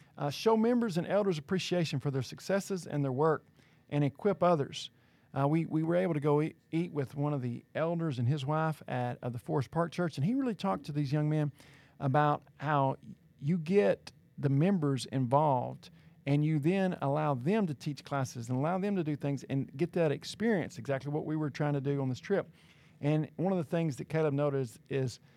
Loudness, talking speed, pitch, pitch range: -32 LUFS, 215 wpm, 150 Hz, 140-170 Hz